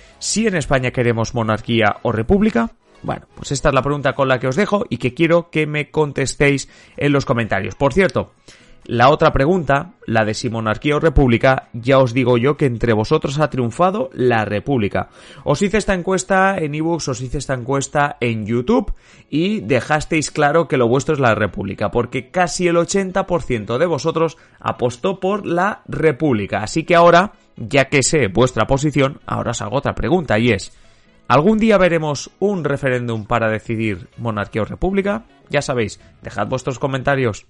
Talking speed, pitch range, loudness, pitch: 175 wpm, 120-165 Hz, -18 LUFS, 140 Hz